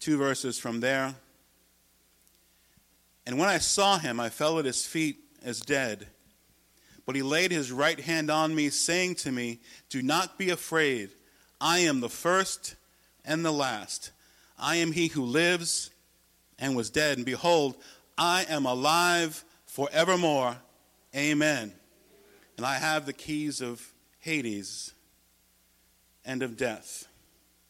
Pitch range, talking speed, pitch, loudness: 115-160 Hz, 135 wpm, 140 Hz, -28 LUFS